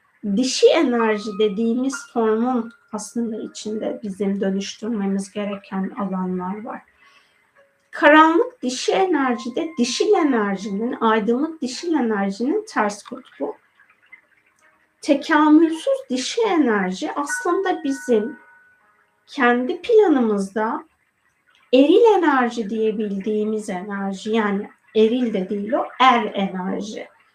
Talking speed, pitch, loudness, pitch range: 85 wpm, 235 Hz, -20 LUFS, 210-295 Hz